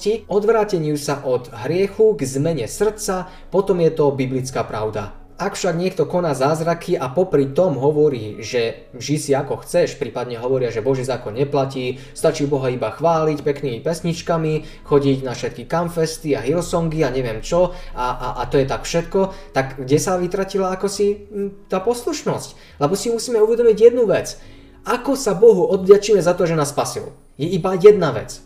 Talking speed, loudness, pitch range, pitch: 170 wpm, -19 LUFS, 135-195 Hz, 160 Hz